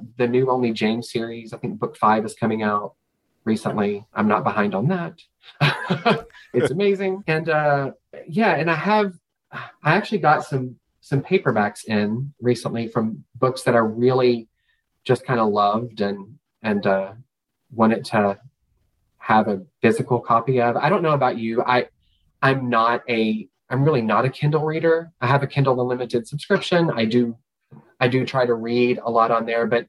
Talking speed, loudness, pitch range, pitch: 175 wpm, -21 LUFS, 110-140 Hz, 120 Hz